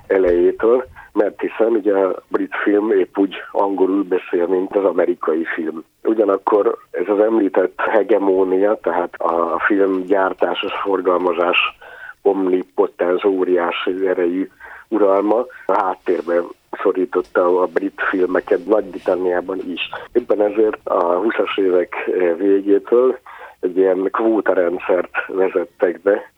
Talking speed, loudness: 110 wpm, -18 LUFS